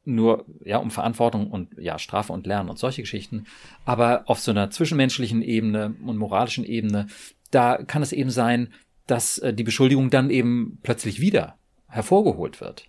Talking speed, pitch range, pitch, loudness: 165 wpm, 105-125 Hz, 115 Hz, -23 LUFS